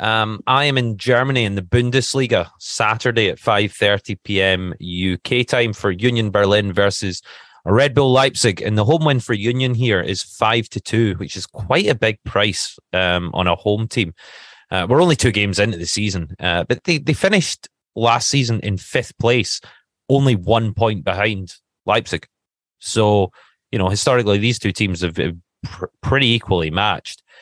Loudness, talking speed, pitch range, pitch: -18 LUFS, 170 wpm, 95-120 Hz, 110 Hz